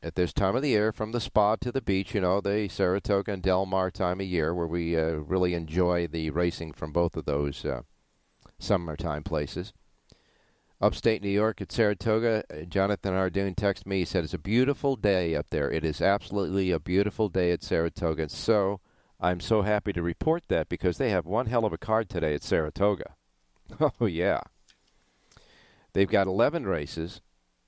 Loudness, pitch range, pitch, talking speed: -28 LUFS, 85-105 Hz, 95 Hz, 185 wpm